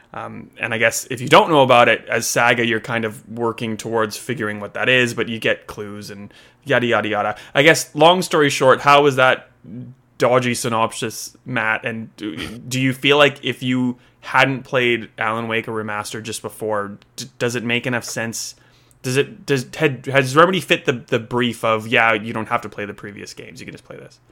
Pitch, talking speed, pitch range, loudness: 120 Hz, 215 wpm, 110-130 Hz, -18 LUFS